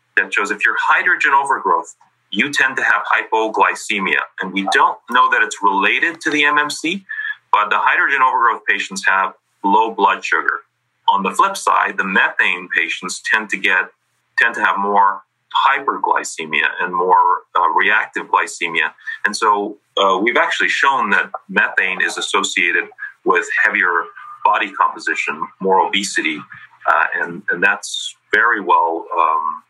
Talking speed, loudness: 145 wpm, -16 LUFS